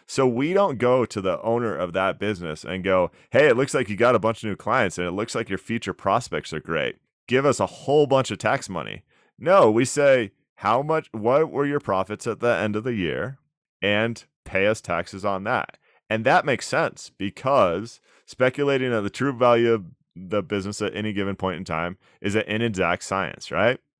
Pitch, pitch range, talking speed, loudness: 105 Hz, 95-125 Hz, 215 wpm, -23 LUFS